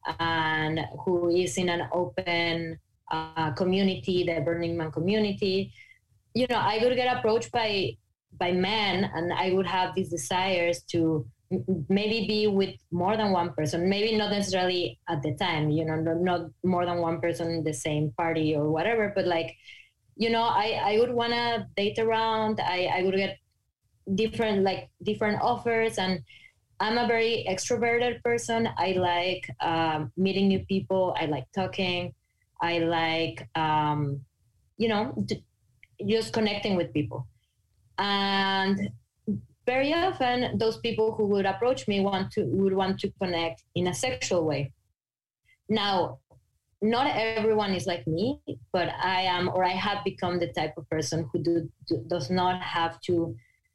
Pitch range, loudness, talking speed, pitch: 165-210 Hz, -27 LUFS, 160 wpm, 185 Hz